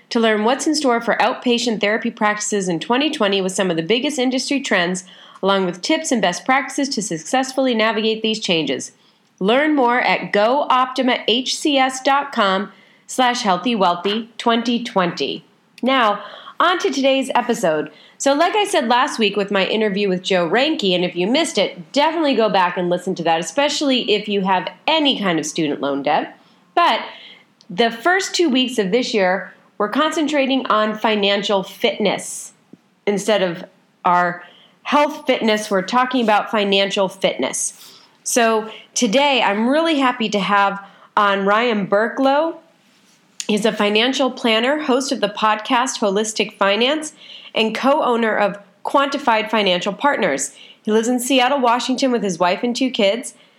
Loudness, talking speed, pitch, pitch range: -18 LUFS, 150 wpm, 220 Hz, 200-260 Hz